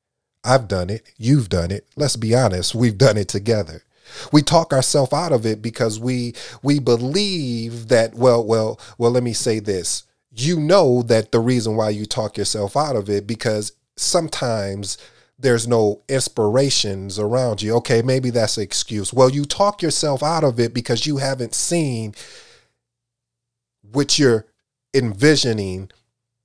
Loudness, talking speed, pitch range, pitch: -19 LUFS, 155 wpm, 110-135 Hz, 120 Hz